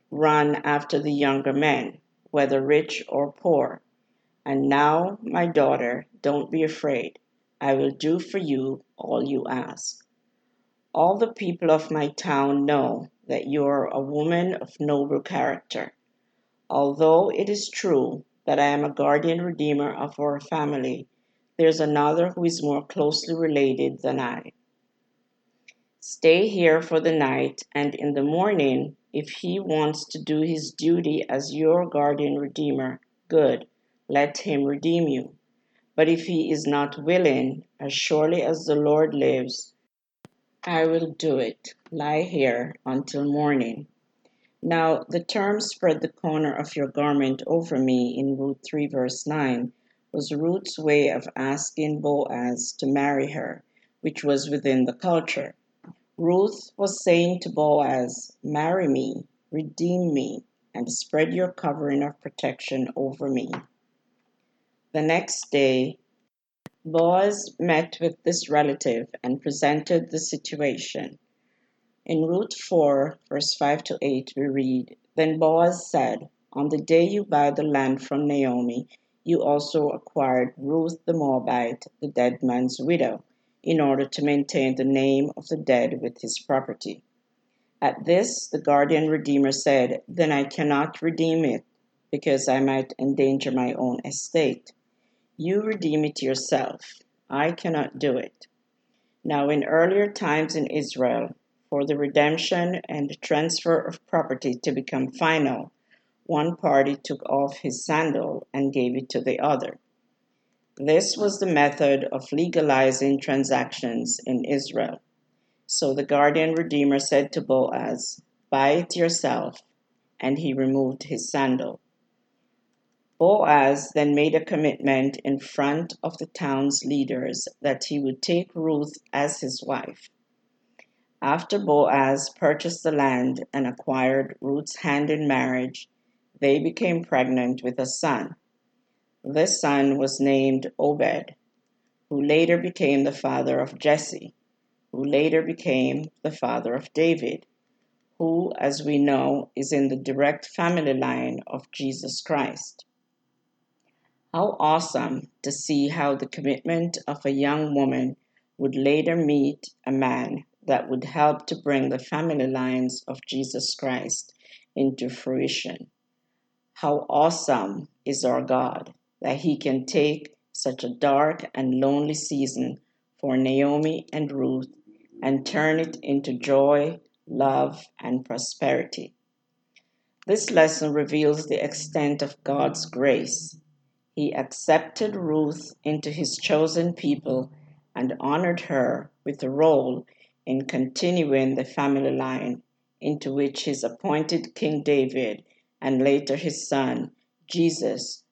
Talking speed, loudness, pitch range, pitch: 135 wpm, -24 LUFS, 135-165 Hz, 145 Hz